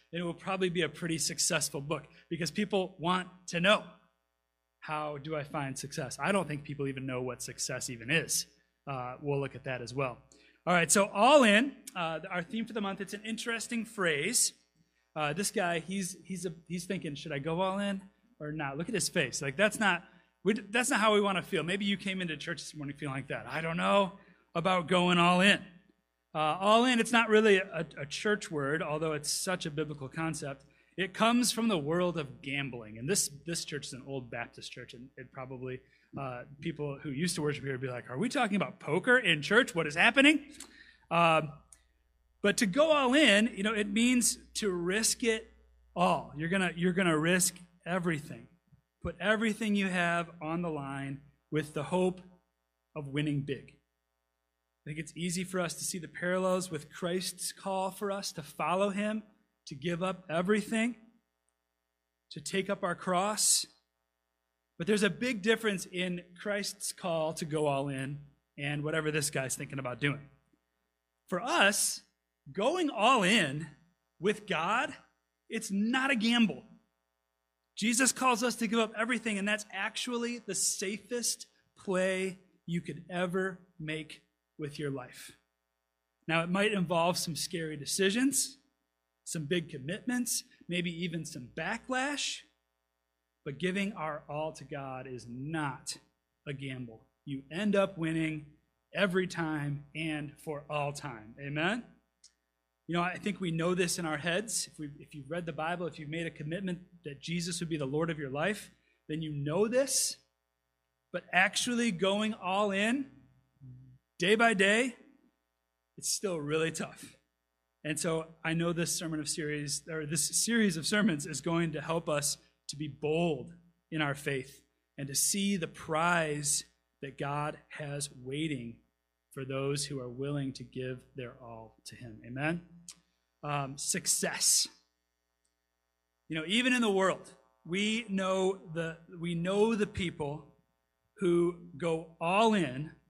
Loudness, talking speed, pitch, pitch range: -31 LUFS, 170 wpm, 165 Hz, 140-195 Hz